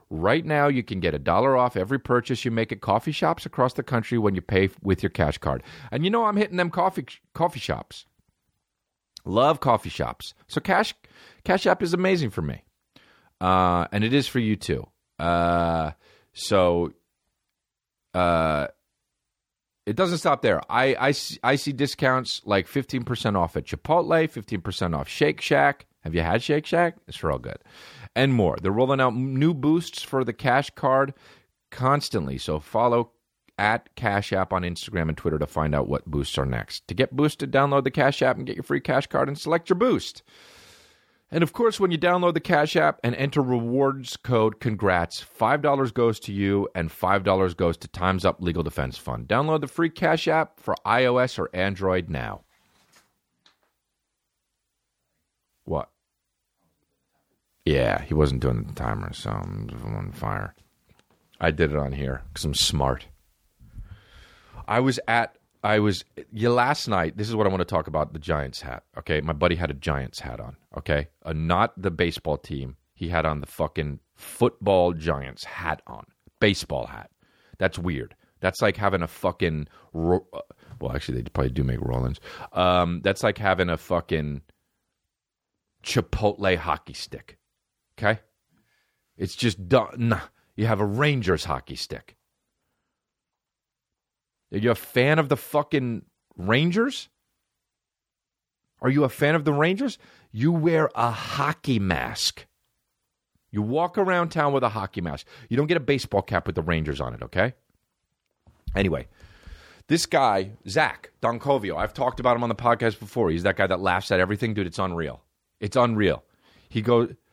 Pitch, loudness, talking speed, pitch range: 105 Hz, -24 LUFS, 170 wpm, 85-130 Hz